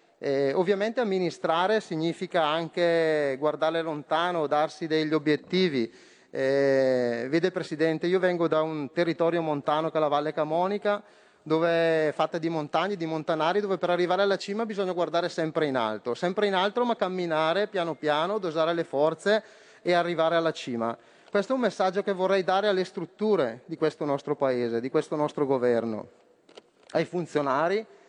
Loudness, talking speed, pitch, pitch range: -27 LUFS, 155 wpm, 165 Hz, 150-185 Hz